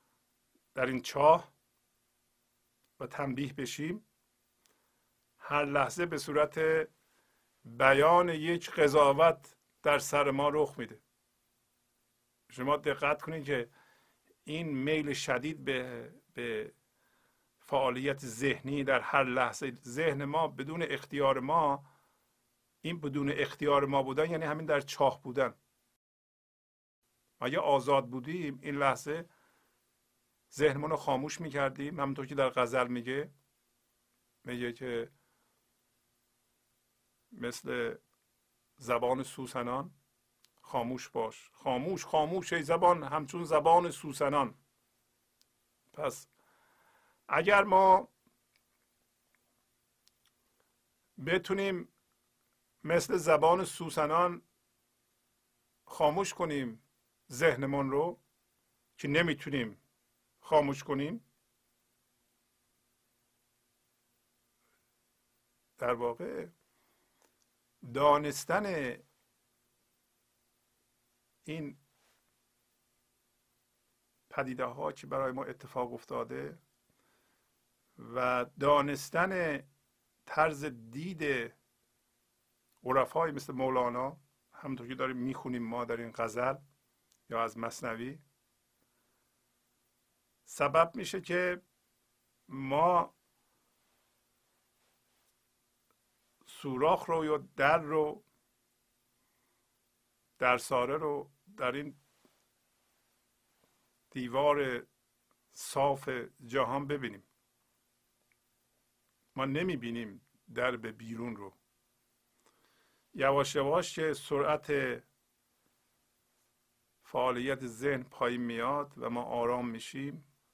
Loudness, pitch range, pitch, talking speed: -32 LUFS, 120-150 Hz, 140 Hz, 75 wpm